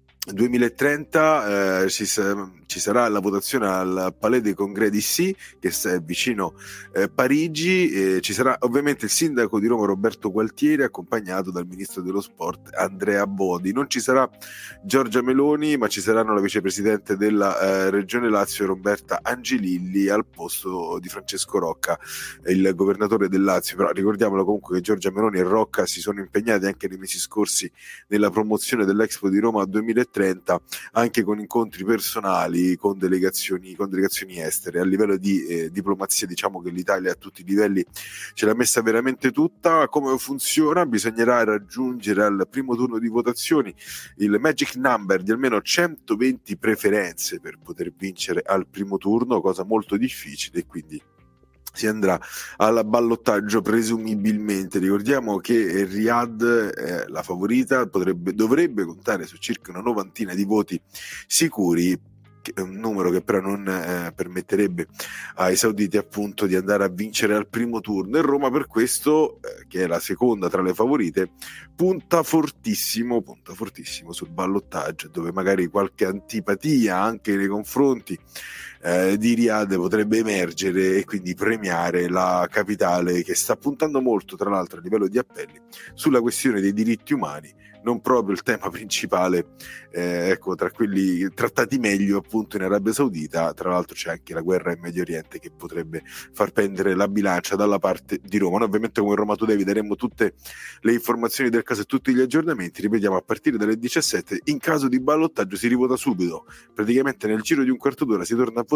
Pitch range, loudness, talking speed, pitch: 95-120 Hz, -22 LUFS, 165 wpm, 105 Hz